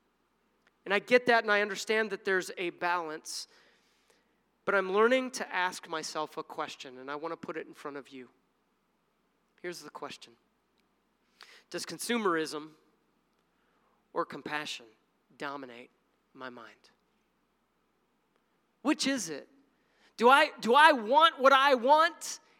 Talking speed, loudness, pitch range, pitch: 135 wpm, -28 LUFS, 155-240 Hz, 205 Hz